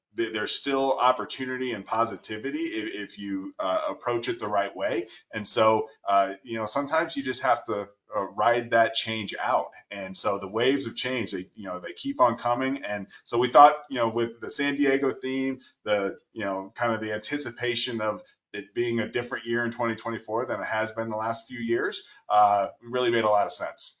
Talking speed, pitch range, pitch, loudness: 210 wpm, 110-130 Hz, 115 Hz, -26 LUFS